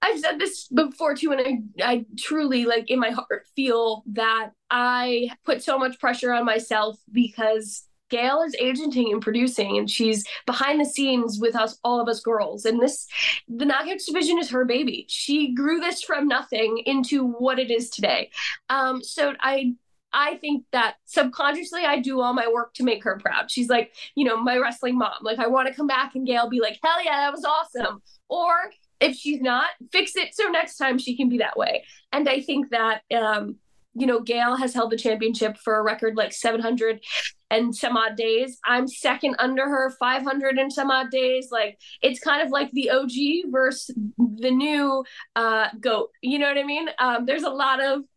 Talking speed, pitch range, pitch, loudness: 200 wpm, 230-280 Hz, 255 Hz, -23 LUFS